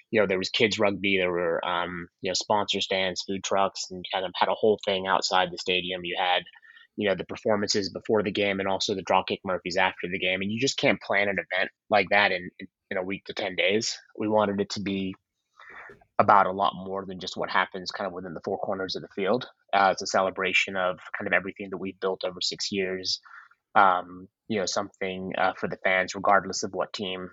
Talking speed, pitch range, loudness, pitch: 235 wpm, 90-100 Hz, -26 LUFS, 95 Hz